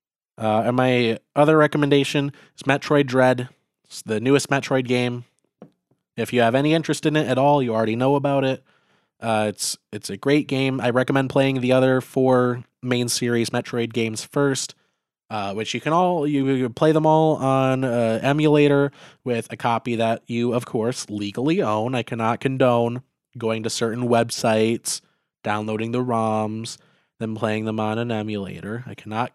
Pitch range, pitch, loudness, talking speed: 115-140 Hz, 125 Hz, -21 LUFS, 170 wpm